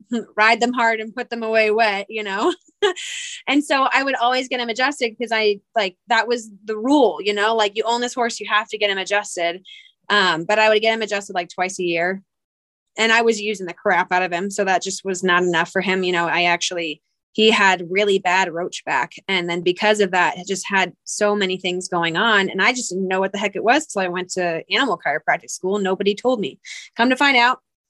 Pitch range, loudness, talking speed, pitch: 185-230 Hz, -19 LUFS, 245 wpm, 205 Hz